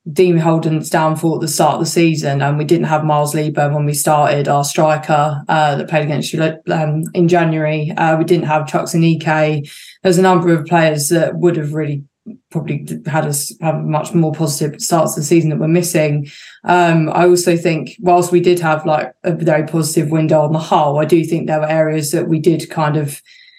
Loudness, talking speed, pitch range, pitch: -15 LUFS, 220 wpm, 155-170 Hz, 160 Hz